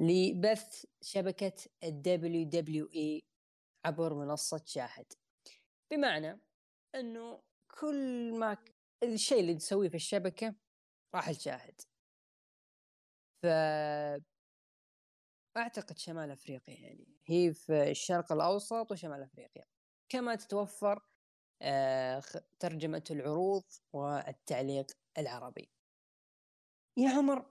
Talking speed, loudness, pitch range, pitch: 80 wpm, -36 LUFS, 150-215 Hz, 175 Hz